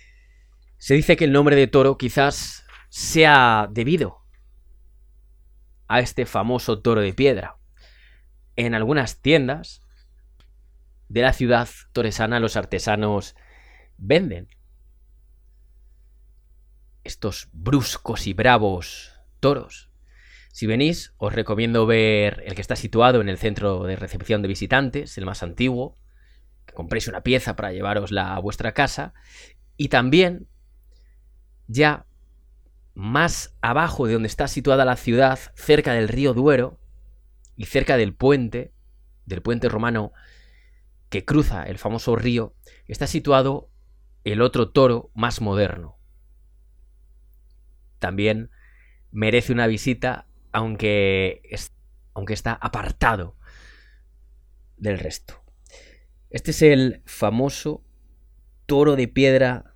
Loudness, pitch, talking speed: -21 LUFS, 105 Hz, 110 wpm